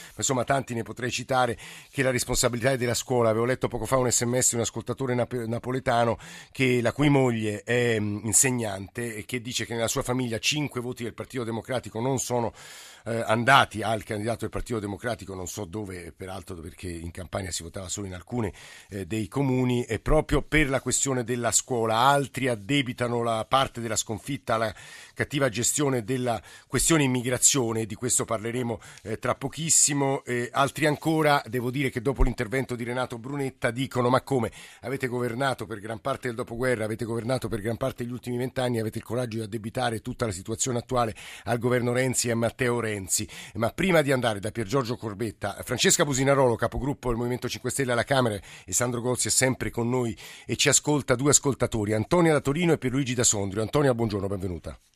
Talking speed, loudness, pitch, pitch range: 190 wpm, -26 LUFS, 120 Hz, 115-130 Hz